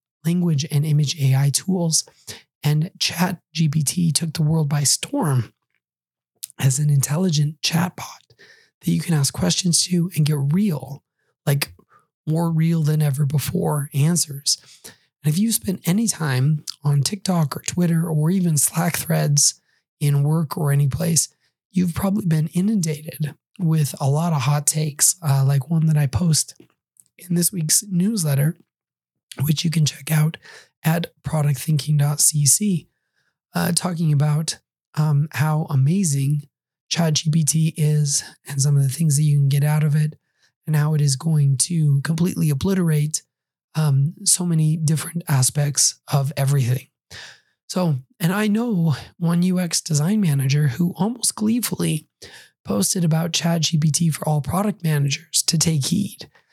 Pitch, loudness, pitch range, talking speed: 155 Hz, -20 LUFS, 145-170 Hz, 145 wpm